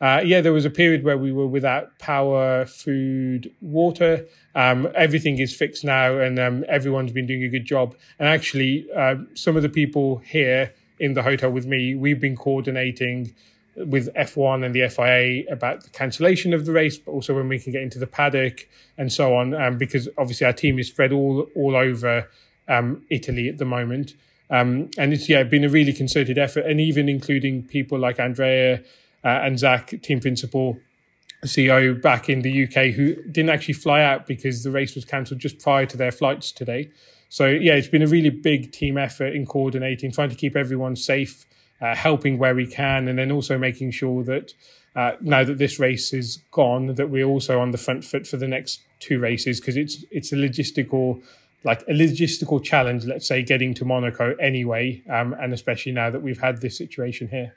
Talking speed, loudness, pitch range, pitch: 200 wpm, -21 LUFS, 130-145 Hz, 135 Hz